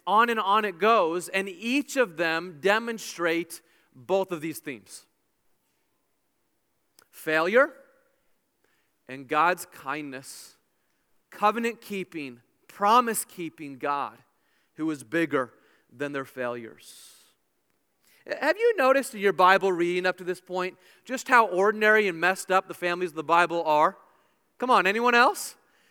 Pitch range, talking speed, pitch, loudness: 160-215 Hz, 130 wpm, 180 Hz, -25 LUFS